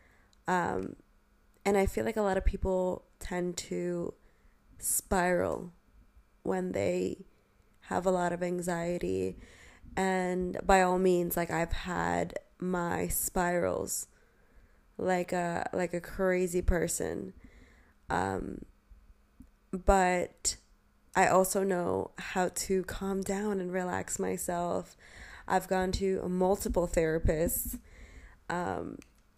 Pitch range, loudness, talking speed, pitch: 175-190 Hz, -31 LUFS, 105 wpm, 180 Hz